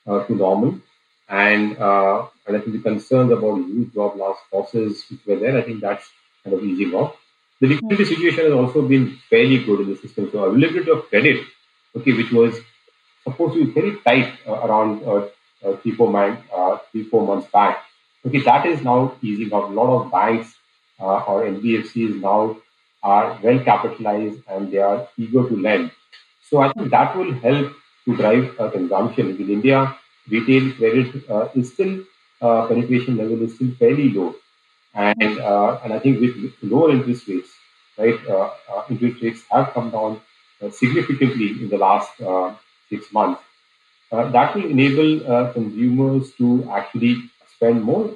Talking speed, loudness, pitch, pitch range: 175 wpm, -19 LUFS, 115 Hz, 105-130 Hz